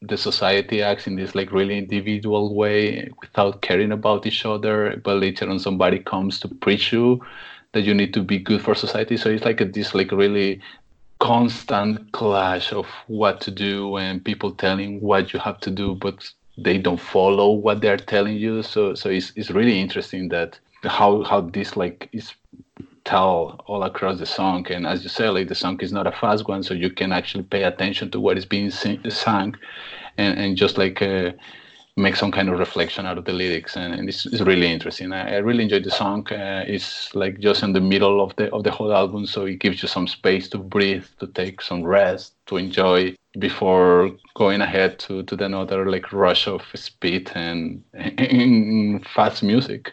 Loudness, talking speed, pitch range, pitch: -21 LUFS, 200 wpm, 95-105 Hz, 100 Hz